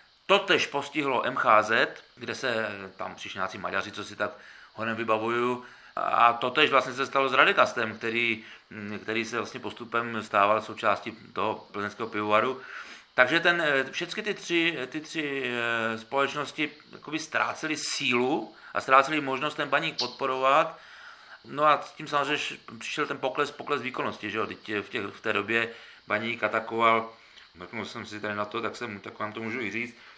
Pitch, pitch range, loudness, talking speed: 120 Hz, 110-140 Hz, -27 LUFS, 155 wpm